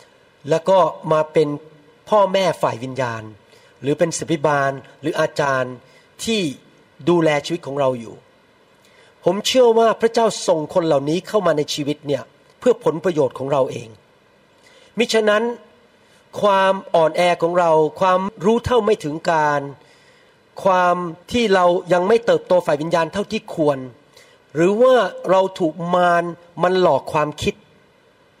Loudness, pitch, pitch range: -18 LUFS, 175 Hz, 155-215 Hz